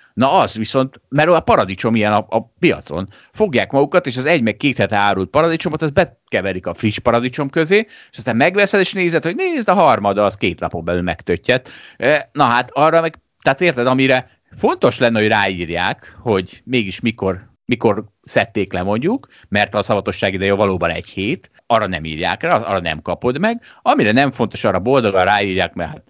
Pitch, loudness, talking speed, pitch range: 120 Hz, -17 LUFS, 180 wpm, 100-155 Hz